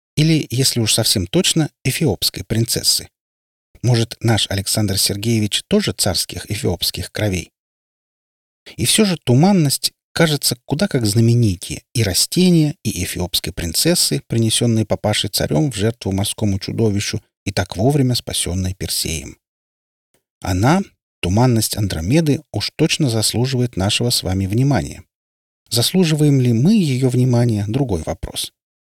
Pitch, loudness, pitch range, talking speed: 115 Hz, -17 LUFS, 95-140 Hz, 120 wpm